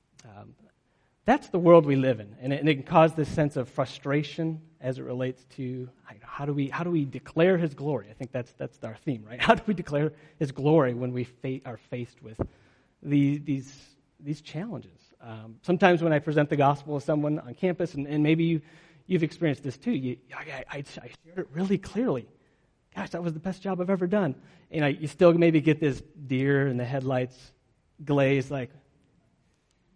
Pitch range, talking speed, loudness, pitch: 130-165 Hz, 210 wpm, -27 LUFS, 145 Hz